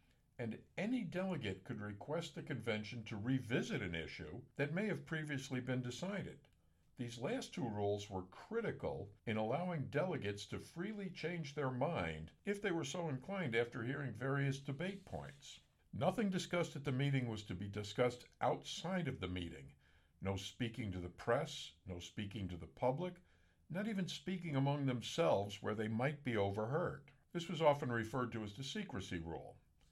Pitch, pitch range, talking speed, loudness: 125 Hz, 100-160 Hz, 165 wpm, -42 LUFS